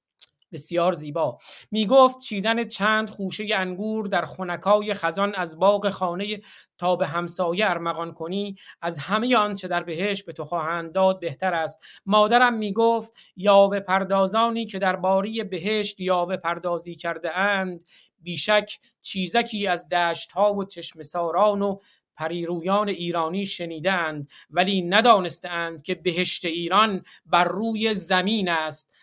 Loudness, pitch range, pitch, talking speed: -23 LUFS, 170-205 Hz, 185 Hz, 130 wpm